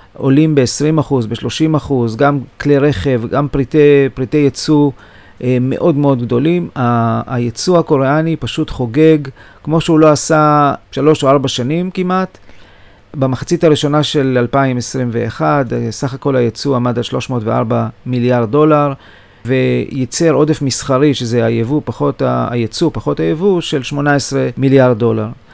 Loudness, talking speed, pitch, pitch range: -13 LUFS, 115 wpm, 135 Hz, 120-150 Hz